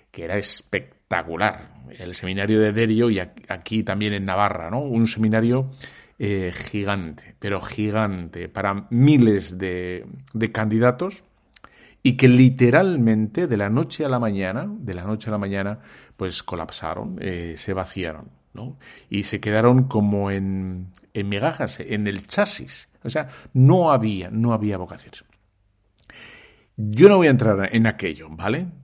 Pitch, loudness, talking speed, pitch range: 105 Hz, -21 LUFS, 150 wpm, 100-120 Hz